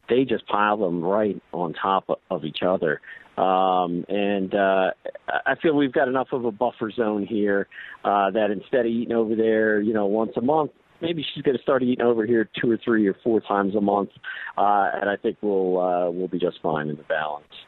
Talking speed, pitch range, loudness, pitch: 215 wpm, 95-115 Hz, -23 LUFS, 105 Hz